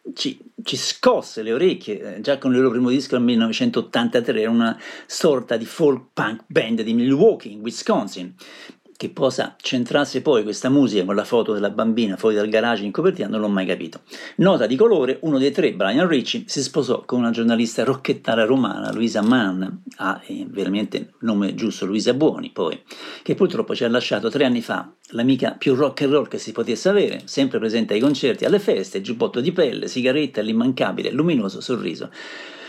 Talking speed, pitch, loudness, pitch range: 185 wpm, 130 Hz, -20 LUFS, 115-150 Hz